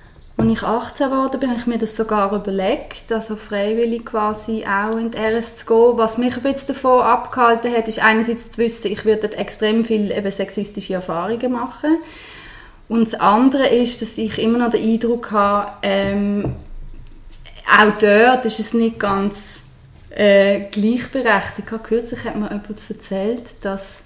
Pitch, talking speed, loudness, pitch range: 220 Hz, 160 wpm, -18 LUFS, 205-235 Hz